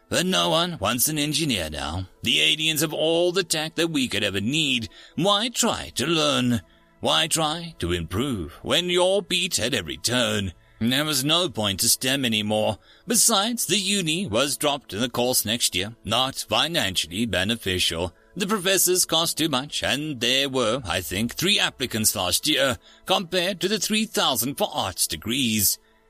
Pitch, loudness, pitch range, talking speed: 135 Hz, -22 LUFS, 110-175 Hz, 170 wpm